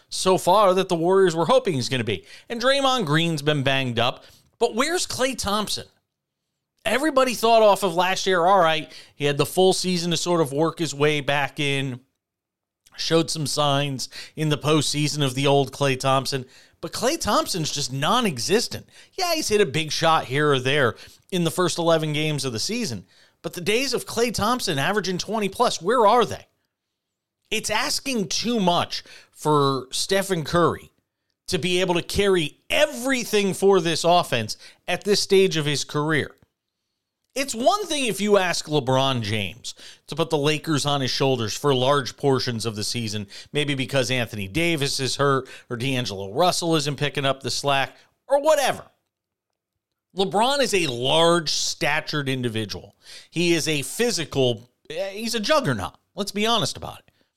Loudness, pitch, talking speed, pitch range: -22 LUFS, 160 Hz, 175 wpm, 135-195 Hz